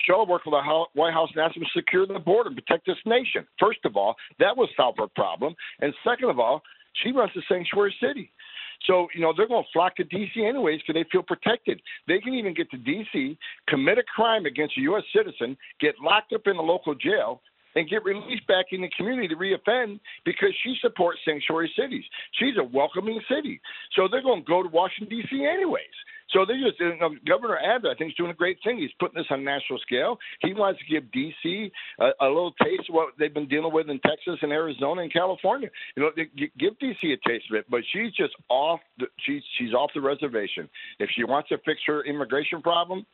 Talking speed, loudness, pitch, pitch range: 230 wpm, -25 LUFS, 185 Hz, 160-240 Hz